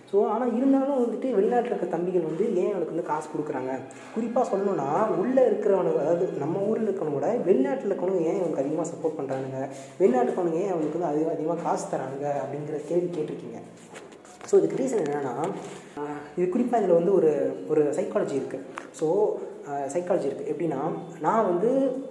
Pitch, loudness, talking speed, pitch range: 180 Hz, -26 LUFS, 155 wpm, 155-235 Hz